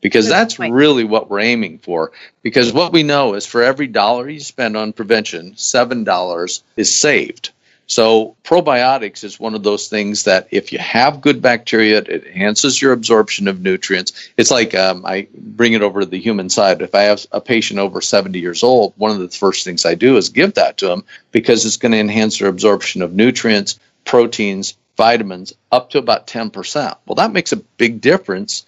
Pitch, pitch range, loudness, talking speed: 110 Hz, 100-120 Hz, -14 LUFS, 195 wpm